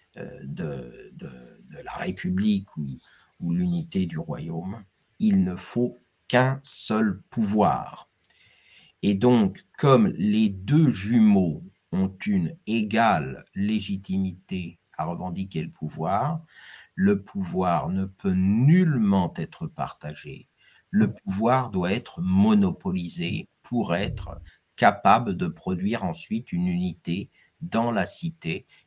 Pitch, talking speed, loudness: 115 Hz, 110 wpm, -25 LUFS